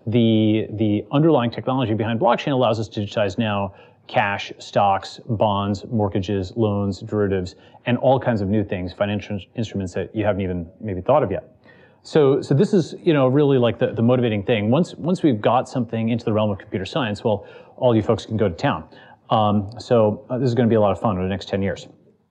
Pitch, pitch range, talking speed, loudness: 110 Hz, 100-125 Hz, 220 wpm, -21 LUFS